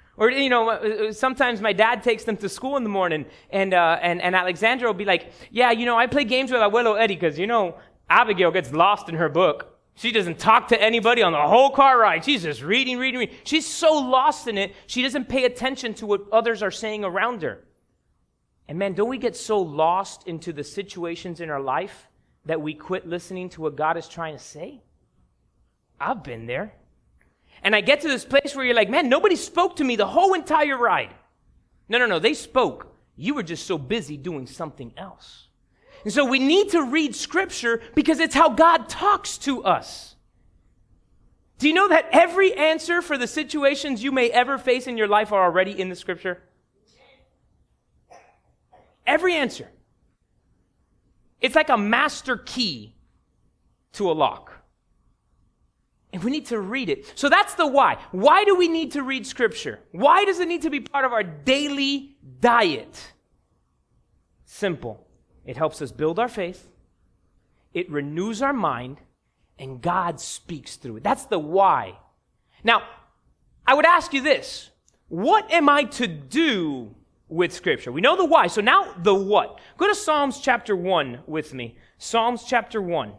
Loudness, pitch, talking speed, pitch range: -21 LUFS, 230 Hz, 180 wpm, 180-280 Hz